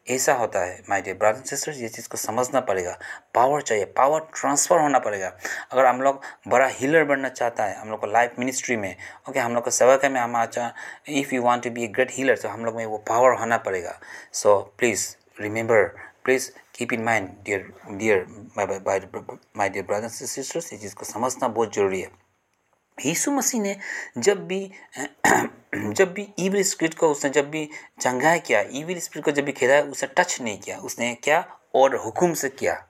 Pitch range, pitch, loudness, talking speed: 115-155 Hz, 130 Hz, -23 LUFS, 205 wpm